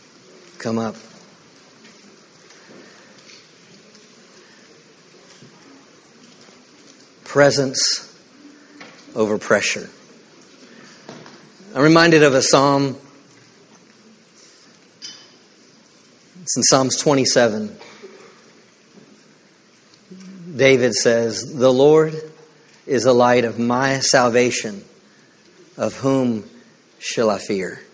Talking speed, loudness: 60 wpm, -17 LUFS